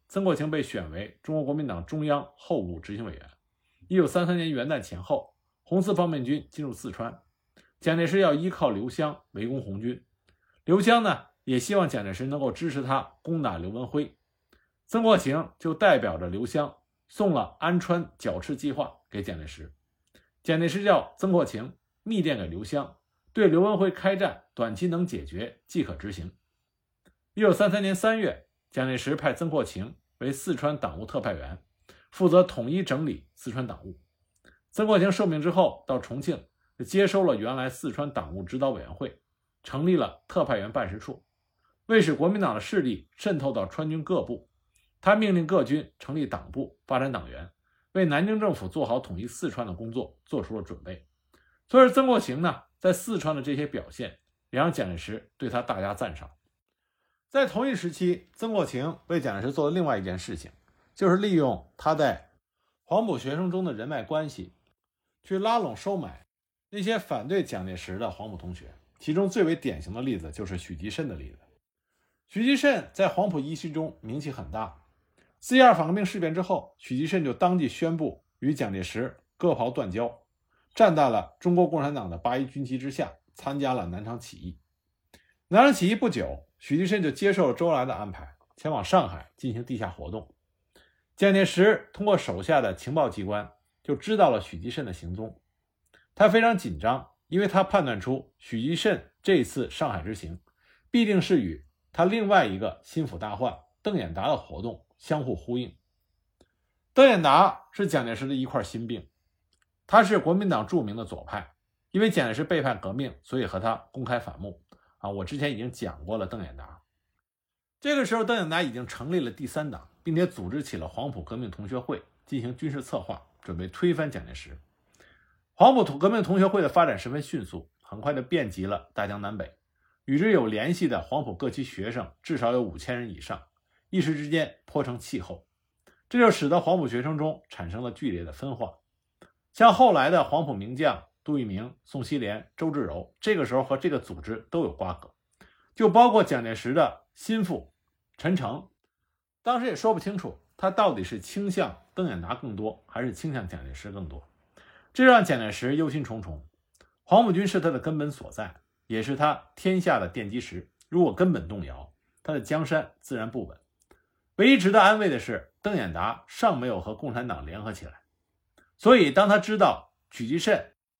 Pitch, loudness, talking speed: 135 Hz, -26 LUFS, 275 characters per minute